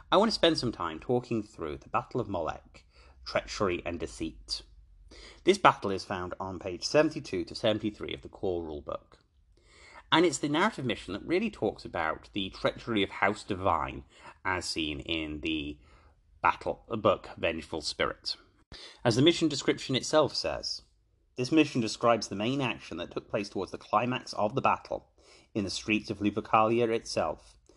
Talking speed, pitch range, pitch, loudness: 170 wpm, 80-125 Hz, 105 Hz, -30 LUFS